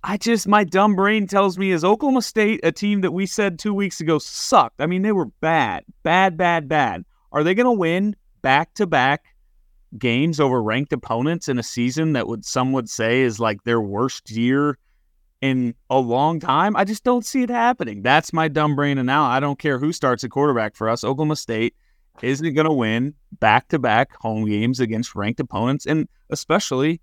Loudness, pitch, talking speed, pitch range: -20 LUFS, 150 Hz, 205 wpm, 120-190 Hz